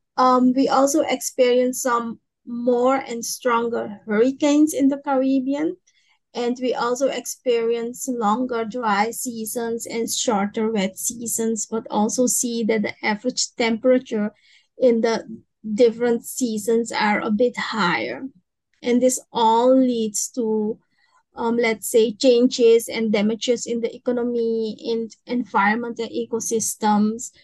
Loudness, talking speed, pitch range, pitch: -21 LUFS, 120 wpm, 225-255 Hz, 235 Hz